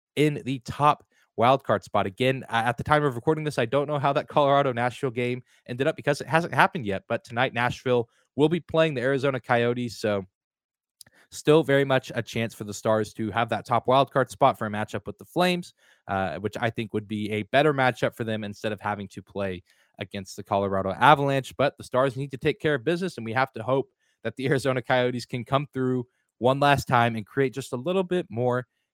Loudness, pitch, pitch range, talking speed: -25 LUFS, 125 Hz, 110-140 Hz, 225 wpm